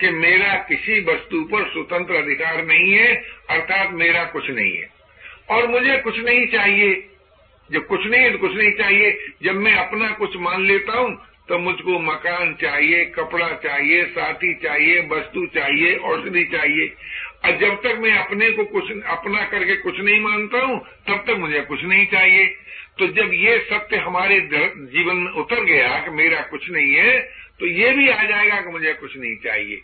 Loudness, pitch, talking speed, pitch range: -17 LUFS, 195 Hz, 180 wpm, 170-225 Hz